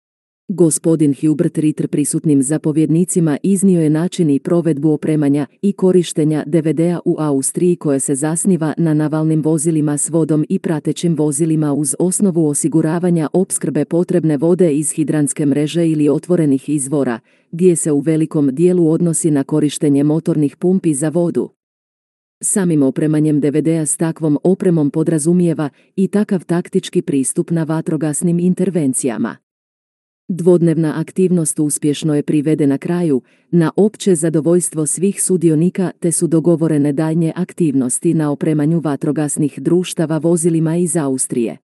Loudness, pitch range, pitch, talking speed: -15 LUFS, 150-175 Hz, 160 Hz, 125 wpm